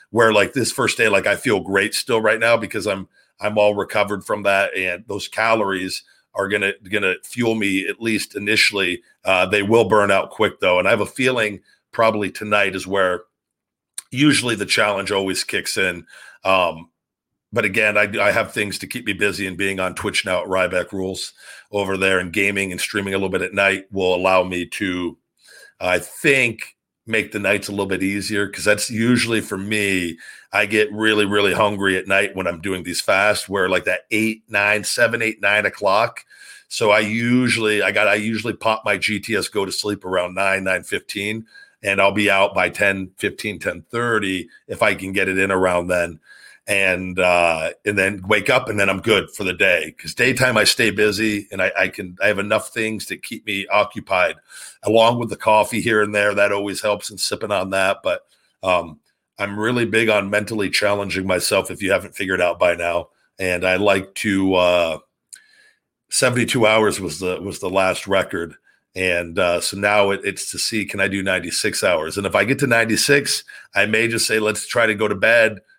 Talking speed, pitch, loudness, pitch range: 205 wpm, 100 Hz, -19 LUFS, 95-110 Hz